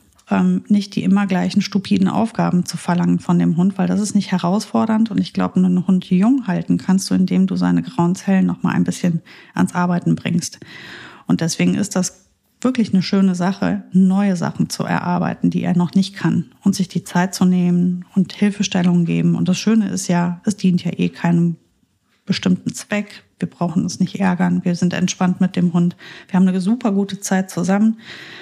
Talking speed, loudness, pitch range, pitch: 195 wpm, -18 LUFS, 175-200 Hz, 185 Hz